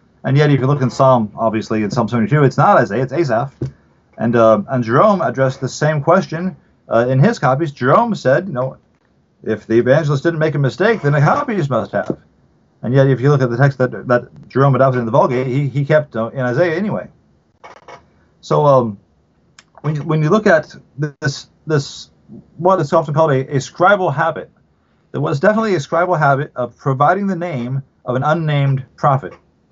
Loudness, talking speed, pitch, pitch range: -16 LUFS, 200 wpm, 135 Hz, 125-155 Hz